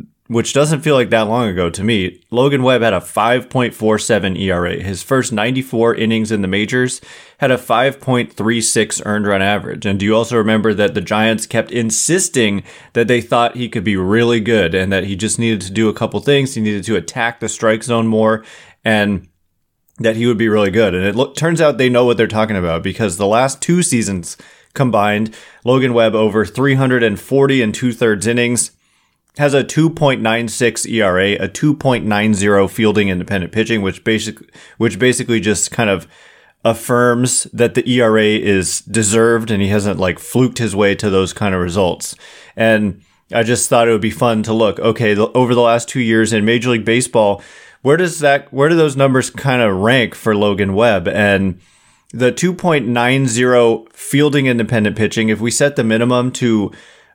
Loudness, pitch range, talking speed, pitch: -15 LUFS, 105-125 Hz, 185 wpm, 115 Hz